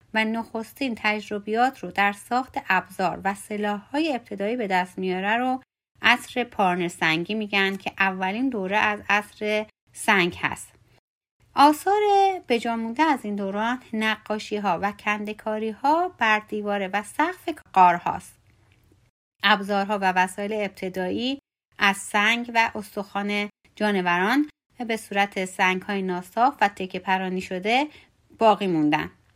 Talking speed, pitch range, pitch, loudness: 130 wpm, 190-230 Hz, 210 Hz, -24 LUFS